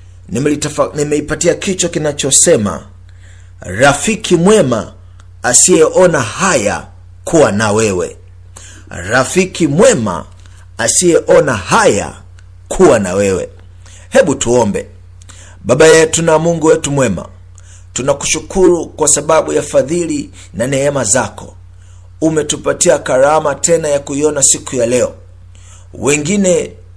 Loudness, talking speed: -11 LUFS, 95 wpm